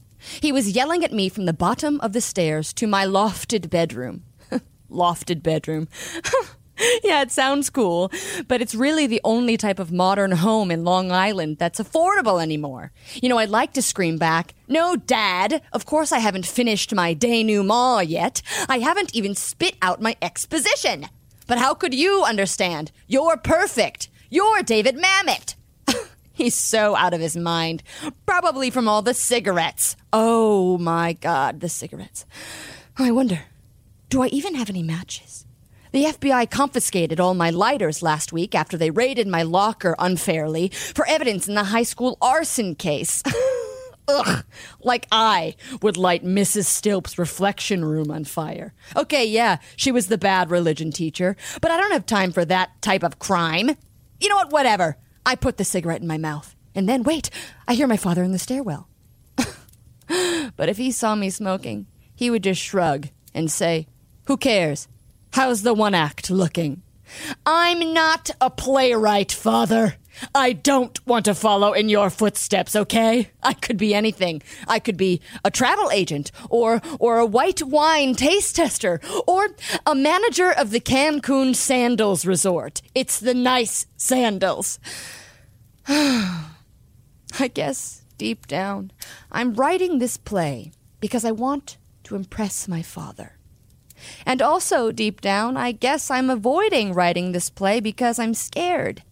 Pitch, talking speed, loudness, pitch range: 215 Hz, 155 wpm, -21 LUFS, 175-260 Hz